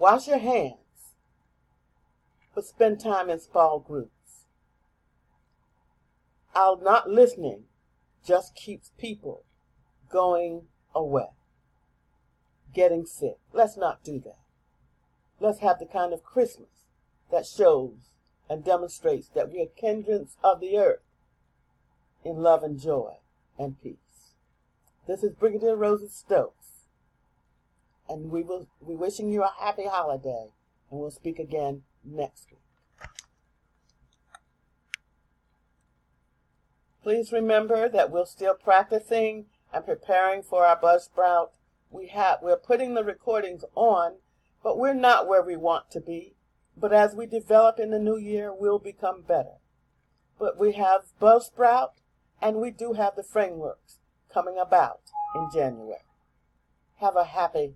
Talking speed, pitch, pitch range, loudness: 125 wpm, 195 Hz, 170-225 Hz, -25 LUFS